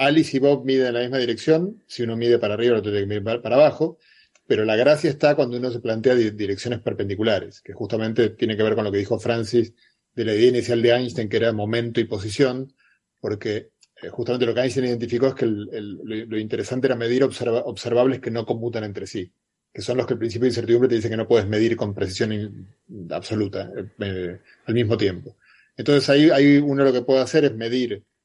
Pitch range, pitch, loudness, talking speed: 110-130 Hz, 120 Hz, -21 LUFS, 220 wpm